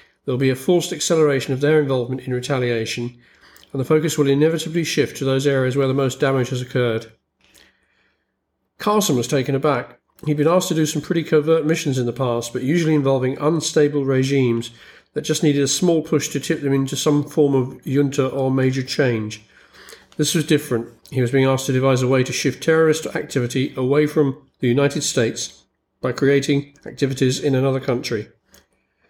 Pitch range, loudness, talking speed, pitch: 130-150 Hz, -19 LUFS, 185 wpm, 135 Hz